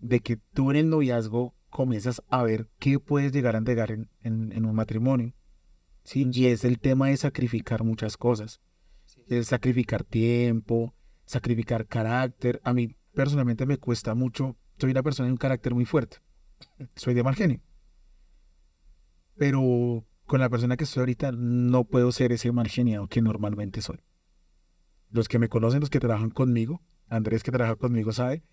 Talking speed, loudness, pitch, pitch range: 165 wpm, -26 LUFS, 120 Hz, 110-130 Hz